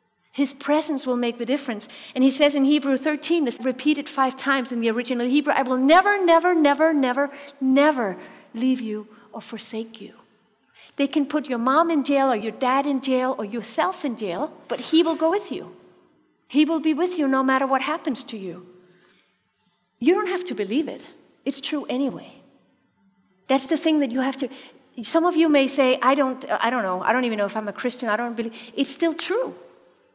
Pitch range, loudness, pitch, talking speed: 235-300 Hz, -22 LUFS, 265 Hz, 210 wpm